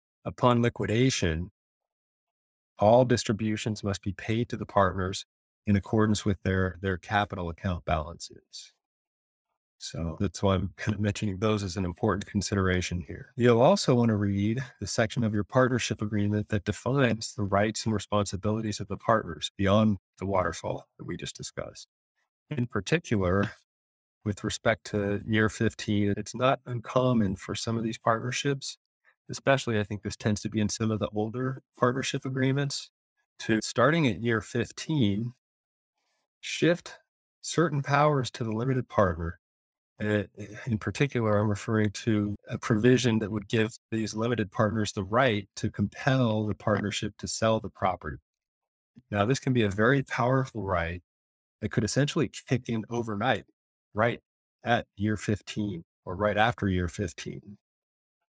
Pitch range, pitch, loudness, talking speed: 100-120 Hz, 105 Hz, -28 LUFS, 150 wpm